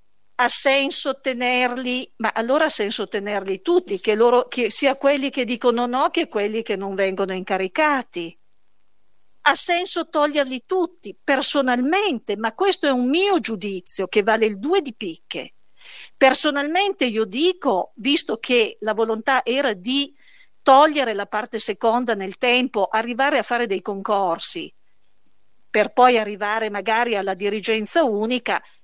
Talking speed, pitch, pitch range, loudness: 140 wpm, 245 Hz, 215-285 Hz, -20 LUFS